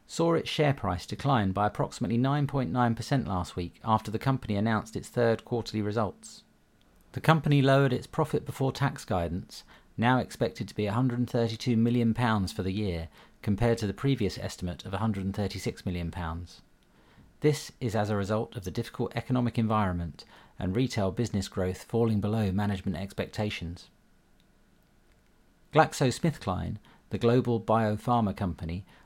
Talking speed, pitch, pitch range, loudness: 135 wpm, 110 Hz, 95-125 Hz, -29 LUFS